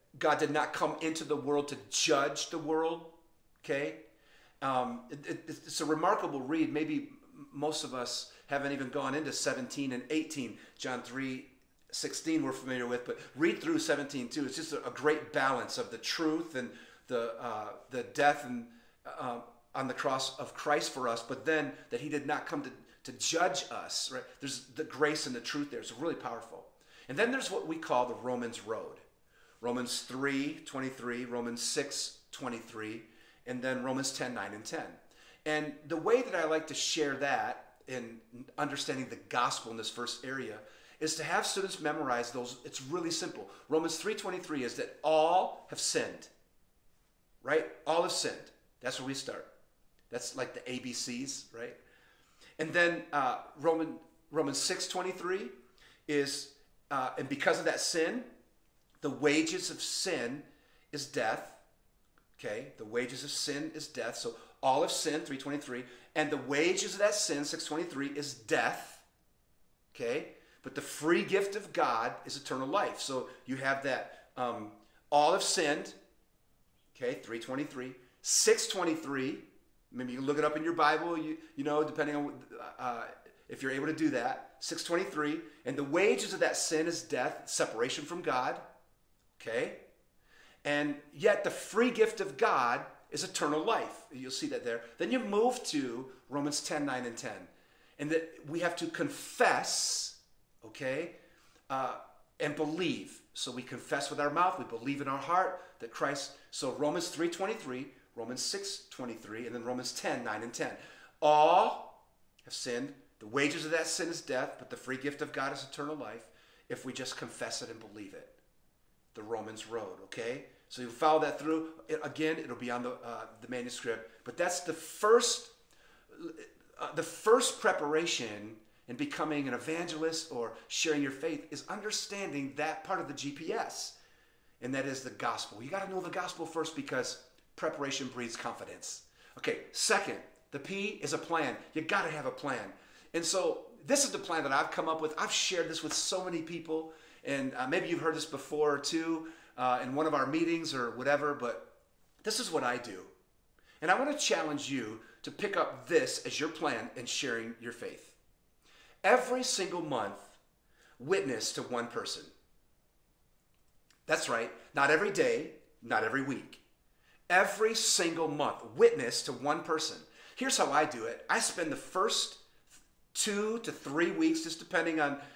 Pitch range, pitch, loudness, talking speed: 130-170 Hz, 150 Hz, -34 LUFS, 170 wpm